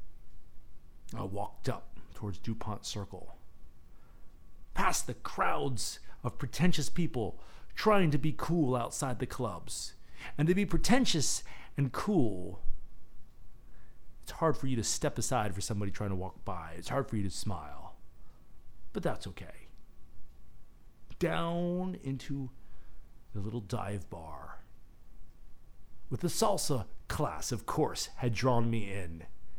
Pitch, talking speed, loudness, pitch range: 120 Hz, 130 wpm, -34 LUFS, 100-145 Hz